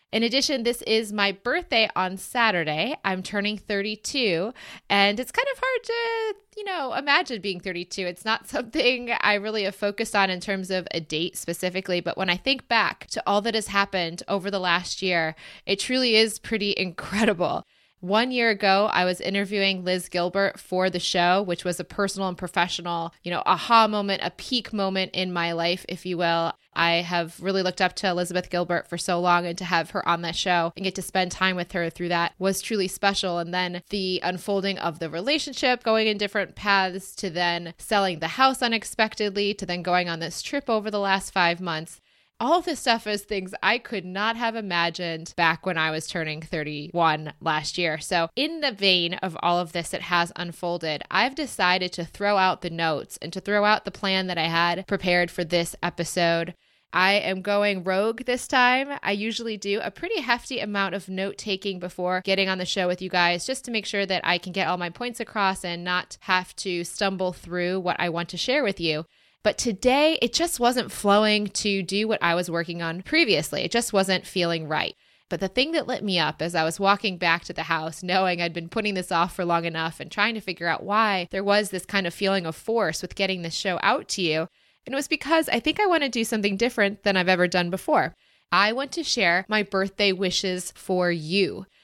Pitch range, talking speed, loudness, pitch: 175-215 Hz, 215 wpm, -24 LUFS, 190 Hz